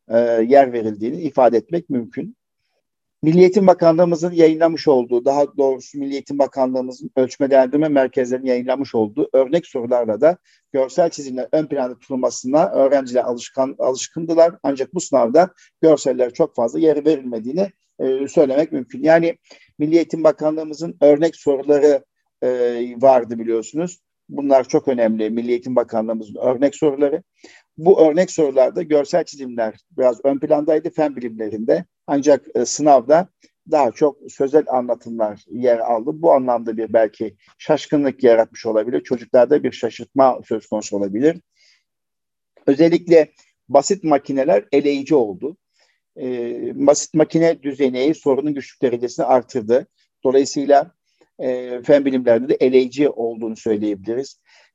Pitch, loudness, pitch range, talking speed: 135 Hz, -18 LUFS, 125-155 Hz, 115 wpm